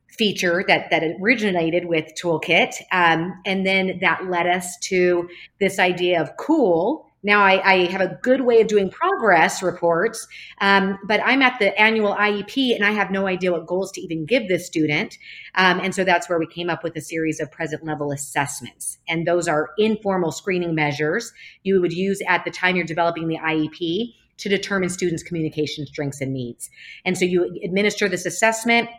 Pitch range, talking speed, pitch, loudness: 165-200 Hz, 190 wpm, 180 Hz, -20 LUFS